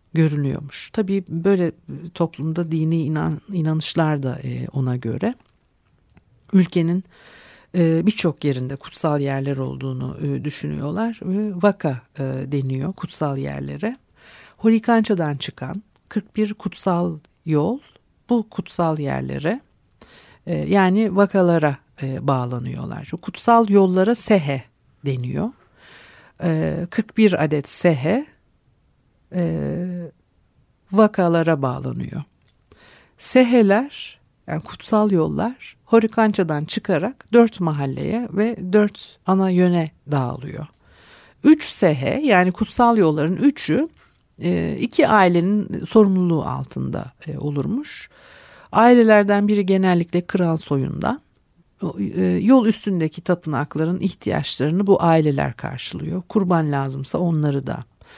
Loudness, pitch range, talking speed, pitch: -20 LUFS, 145-210 Hz, 85 wpm, 175 Hz